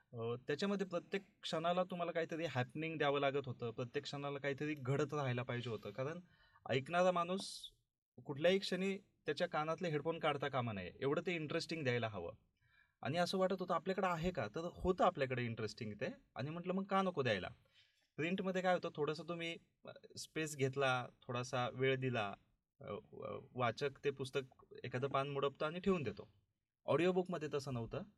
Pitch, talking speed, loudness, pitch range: 145 Hz, 155 wpm, -40 LUFS, 125-175 Hz